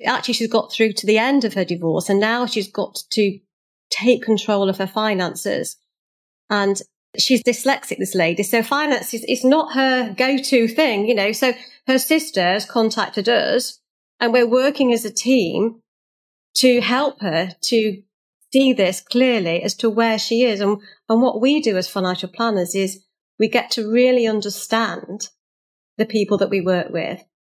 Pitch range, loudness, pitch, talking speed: 200-250 Hz, -19 LUFS, 225 Hz, 170 wpm